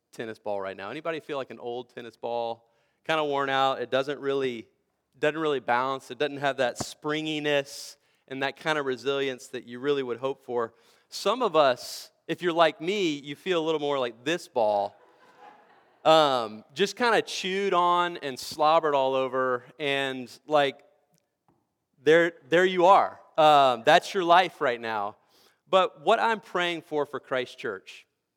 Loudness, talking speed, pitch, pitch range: -26 LUFS, 175 wpm, 140 Hz, 125-160 Hz